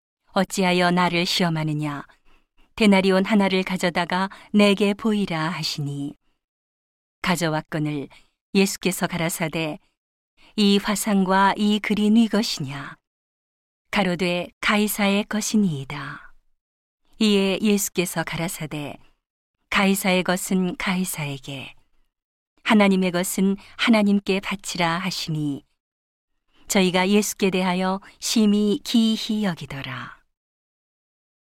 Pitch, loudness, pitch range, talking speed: 190 Hz, -22 LUFS, 165-205 Hz, 230 characters per minute